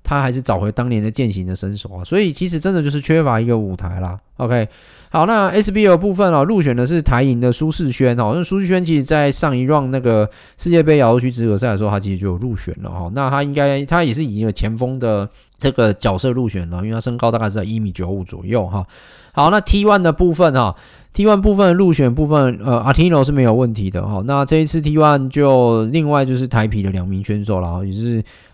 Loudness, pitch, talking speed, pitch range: -16 LUFS, 125 Hz, 385 characters per minute, 105-155 Hz